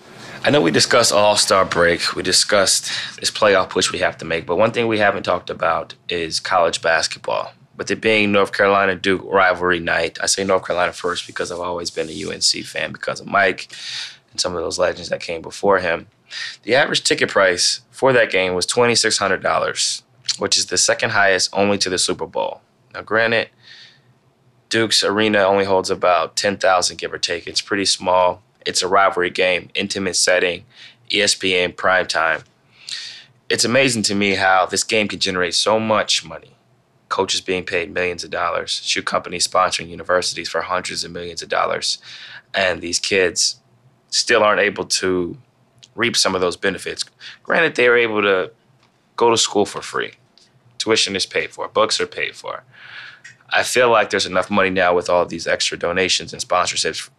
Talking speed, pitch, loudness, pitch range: 180 wpm, 95 Hz, -18 LUFS, 90-110 Hz